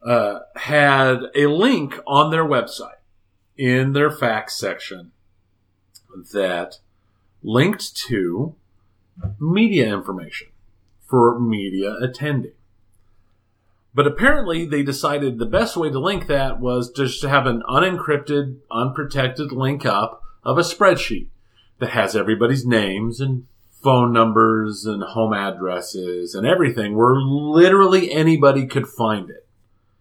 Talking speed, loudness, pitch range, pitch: 120 wpm, -19 LUFS, 100-140 Hz, 120 Hz